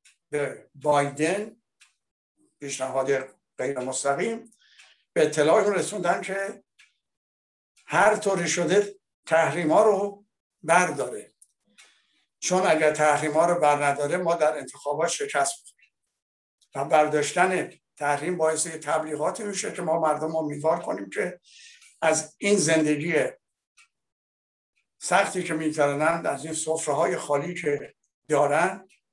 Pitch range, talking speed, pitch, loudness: 145-185 Hz, 105 wpm, 160 Hz, -25 LUFS